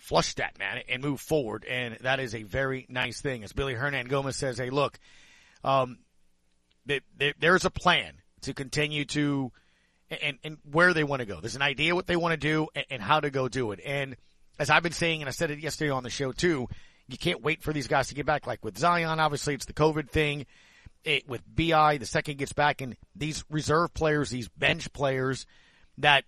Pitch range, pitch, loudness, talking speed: 130-155 Hz, 140 Hz, -28 LUFS, 220 wpm